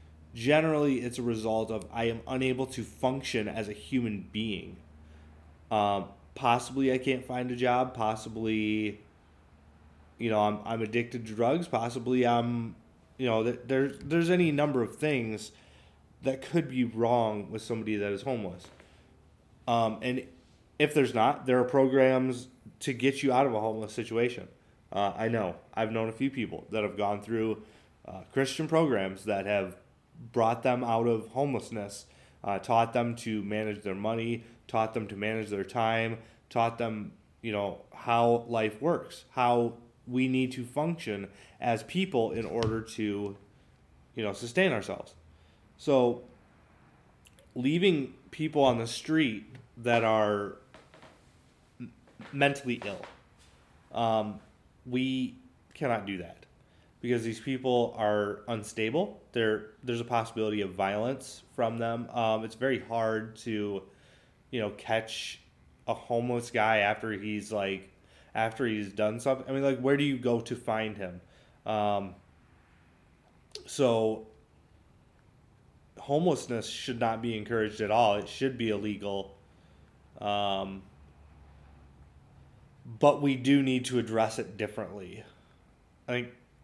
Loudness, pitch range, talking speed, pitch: -30 LUFS, 105-125 Hz, 140 wpm, 115 Hz